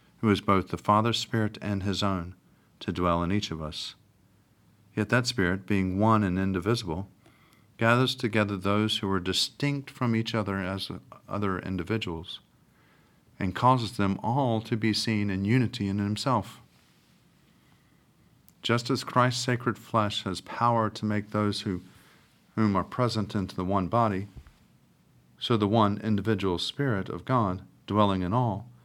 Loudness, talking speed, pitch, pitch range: -28 LUFS, 150 wpm, 105 Hz, 95-115 Hz